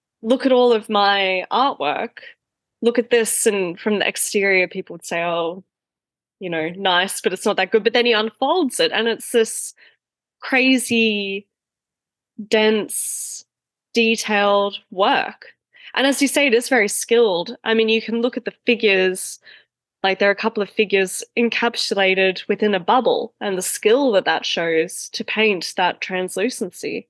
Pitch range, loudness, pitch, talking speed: 190-235 Hz, -19 LUFS, 215 Hz, 165 wpm